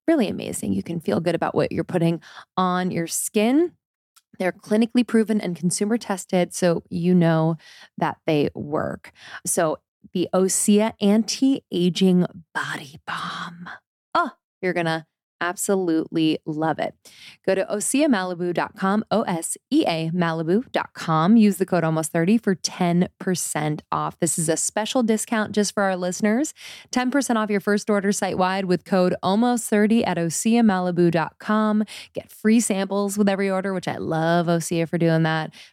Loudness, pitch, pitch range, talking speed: -22 LUFS, 190 Hz, 175-215 Hz, 150 wpm